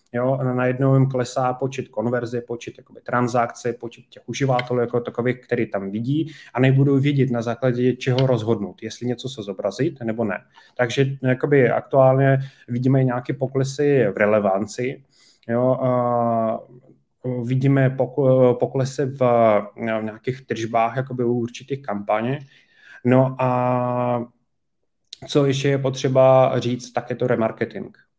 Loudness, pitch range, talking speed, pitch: -21 LUFS, 120-130 Hz, 125 wpm, 125 Hz